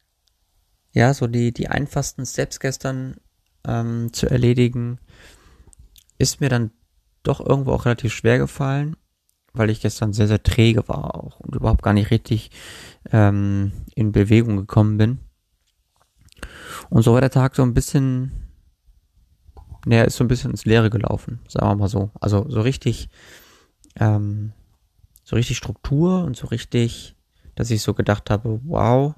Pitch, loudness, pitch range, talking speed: 110 Hz, -20 LUFS, 100-125 Hz, 150 wpm